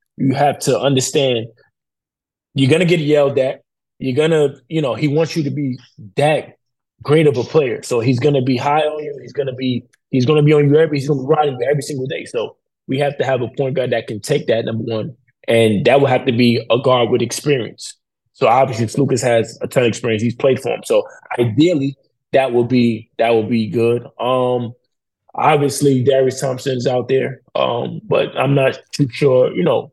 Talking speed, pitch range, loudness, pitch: 215 wpm, 120-145 Hz, -16 LUFS, 135 Hz